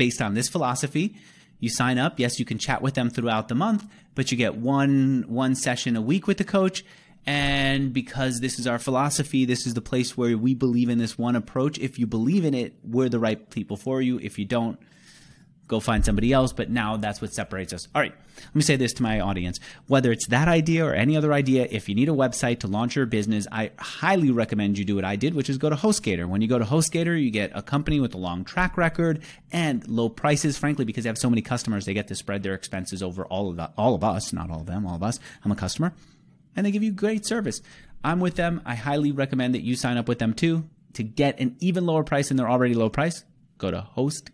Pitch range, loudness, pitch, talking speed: 110-150 Hz, -25 LUFS, 125 Hz, 255 wpm